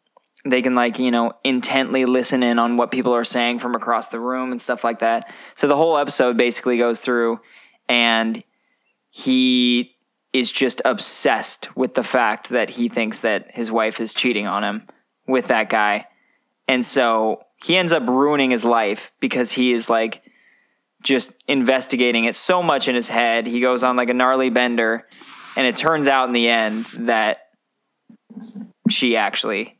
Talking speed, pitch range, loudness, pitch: 175 wpm, 115-130 Hz, -19 LUFS, 125 Hz